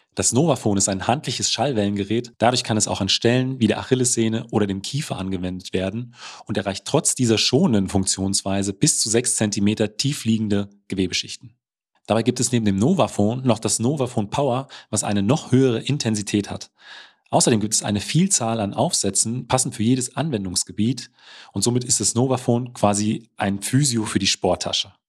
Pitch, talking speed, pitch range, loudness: 110 Hz, 170 wpm, 100-125 Hz, -21 LUFS